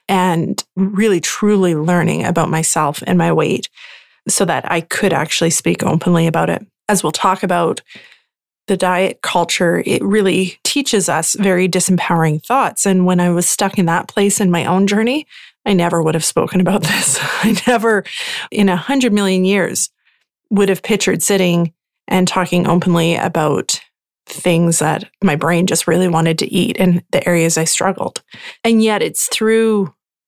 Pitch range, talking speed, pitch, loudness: 170-200 Hz, 165 wpm, 185 Hz, -15 LUFS